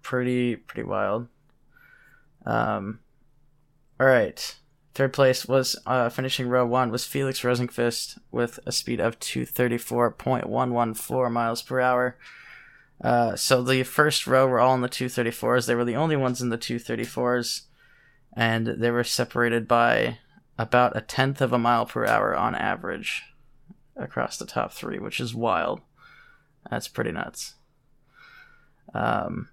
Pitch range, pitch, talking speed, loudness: 120-130 Hz, 125 Hz, 140 wpm, -25 LUFS